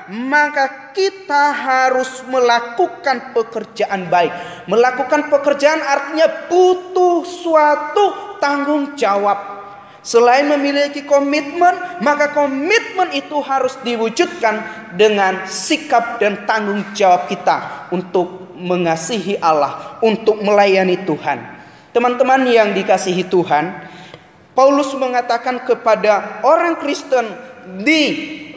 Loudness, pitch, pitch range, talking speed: -16 LUFS, 245 Hz, 200-290 Hz, 90 wpm